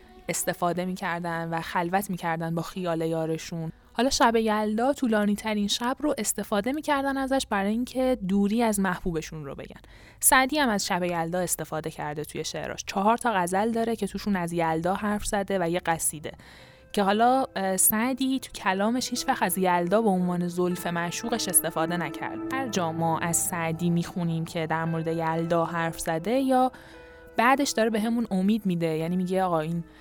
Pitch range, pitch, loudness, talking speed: 165-220 Hz, 185 Hz, -26 LUFS, 170 wpm